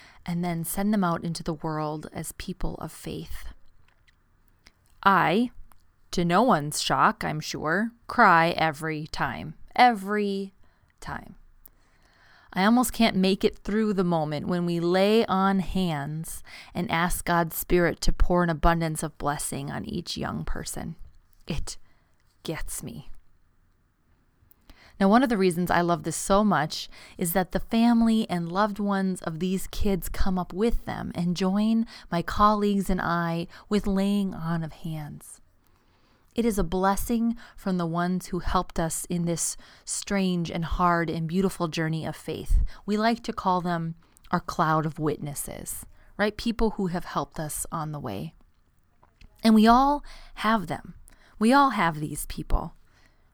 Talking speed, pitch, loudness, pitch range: 155 wpm, 180 Hz, -26 LUFS, 160-205 Hz